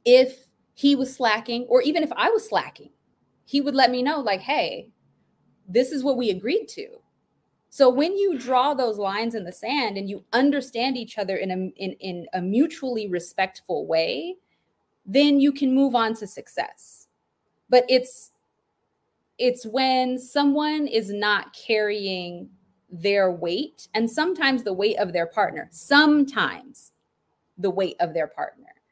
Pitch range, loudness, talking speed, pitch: 200-280 Hz, -23 LUFS, 155 wpm, 250 Hz